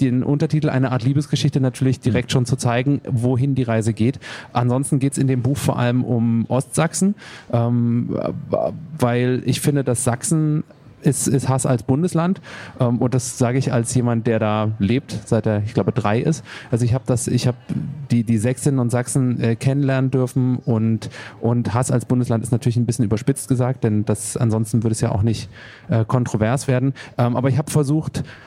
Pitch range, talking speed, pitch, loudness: 120-135 Hz, 195 wpm, 125 Hz, -20 LUFS